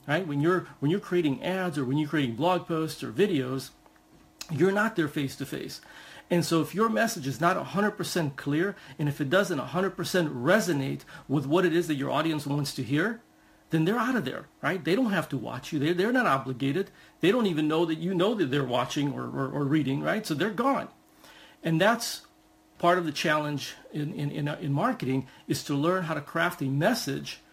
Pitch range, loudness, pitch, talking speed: 145-180 Hz, -28 LUFS, 155 Hz, 215 wpm